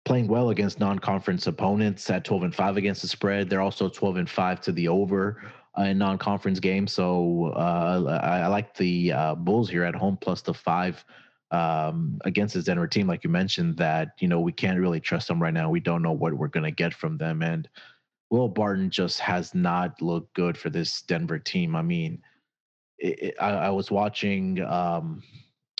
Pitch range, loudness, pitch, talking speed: 85-105 Hz, -26 LUFS, 95 Hz, 205 wpm